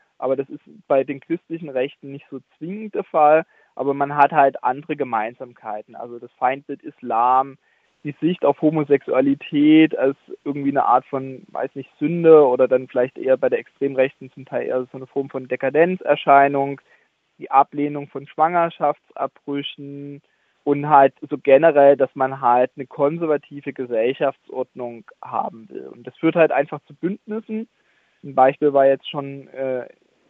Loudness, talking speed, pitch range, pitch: -19 LUFS, 155 wpm, 135-155 Hz, 140 Hz